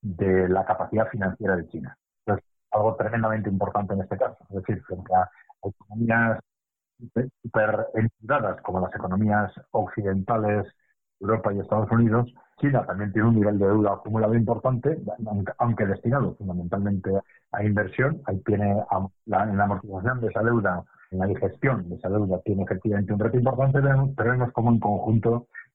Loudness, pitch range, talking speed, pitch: -25 LUFS, 95-115 Hz, 155 wpm, 105 Hz